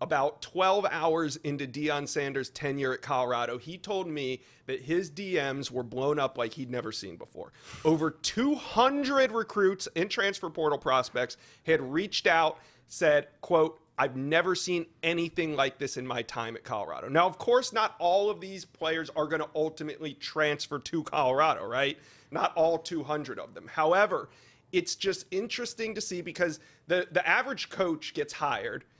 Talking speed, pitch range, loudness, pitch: 165 wpm, 140-185 Hz, -29 LUFS, 160 Hz